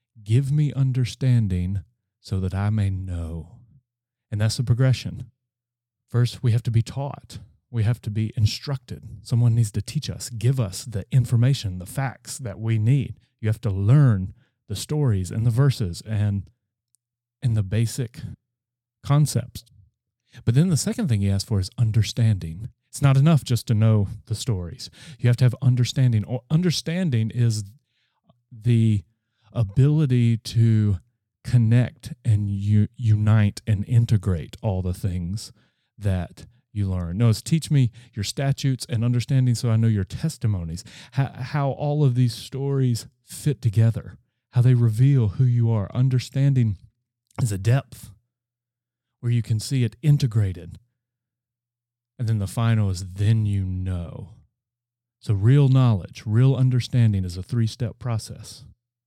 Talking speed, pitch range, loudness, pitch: 145 wpm, 105-125 Hz, -23 LUFS, 120 Hz